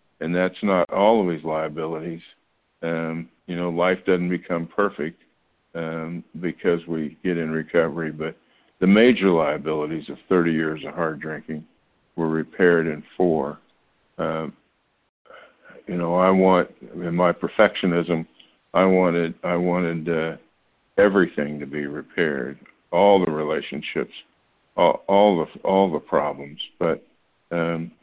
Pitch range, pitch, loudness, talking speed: 80-90 Hz, 85 Hz, -22 LUFS, 135 wpm